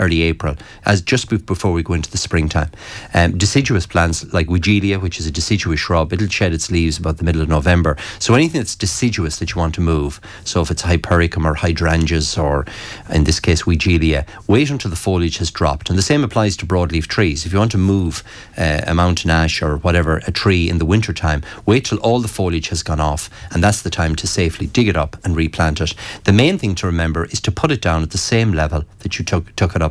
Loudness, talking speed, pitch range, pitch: -17 LUFS, 235 wpm, 80-105 Hz, 90 Hz